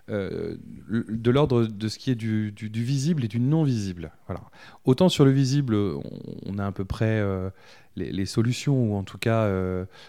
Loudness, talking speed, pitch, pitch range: -25 LUFS, 200 wpm, 110 Hz, 100-130 Hz